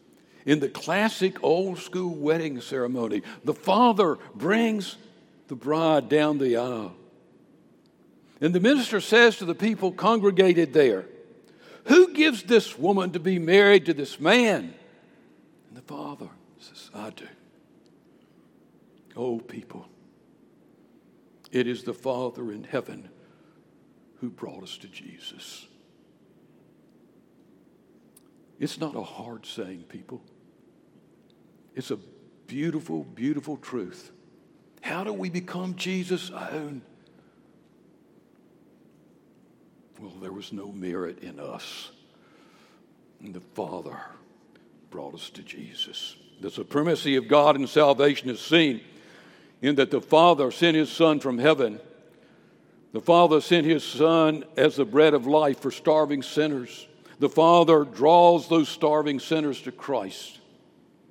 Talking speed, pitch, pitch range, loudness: 120 wpm, 155 Hz, 140-180 Hz, -23 LUFS